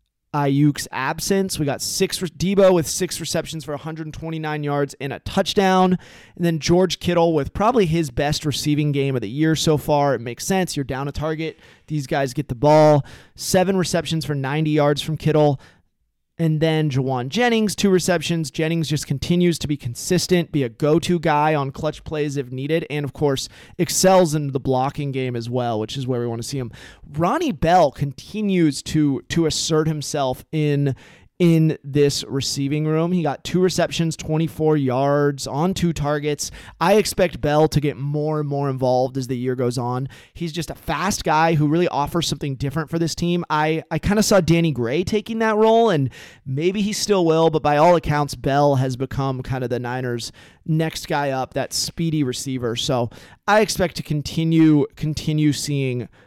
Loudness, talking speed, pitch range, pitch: -20 LUFS, 190 wpm, 135-165 Hz, 150 Hz